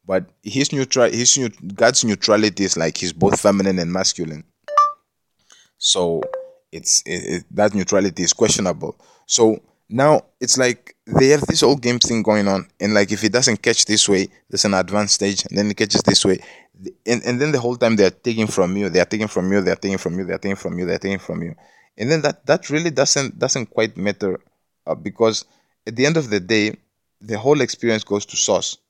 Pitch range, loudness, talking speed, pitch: 100-120 Hz, -18 LUFS, 220 wpm, 105 Hz